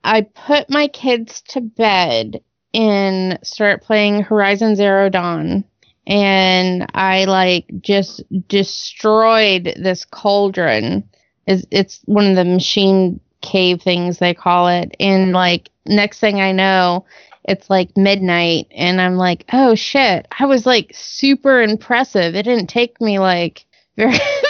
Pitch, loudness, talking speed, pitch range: 195 Hz, -15 LUFS, 135 wpm, 180-220 Hz